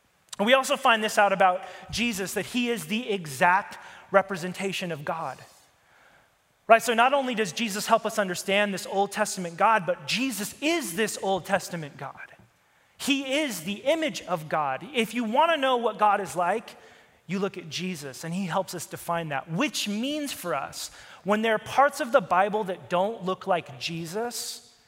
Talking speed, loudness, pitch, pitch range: 185 wpm, -26 LUFS, 200 Hz, 180-235 Hz